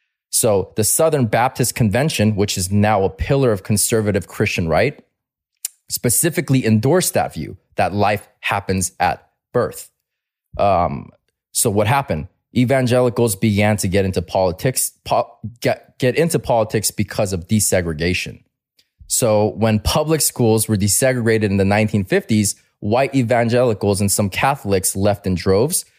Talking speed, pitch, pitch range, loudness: 135 wpm, 110 Hz, 100-125 Hz, -18 LUFS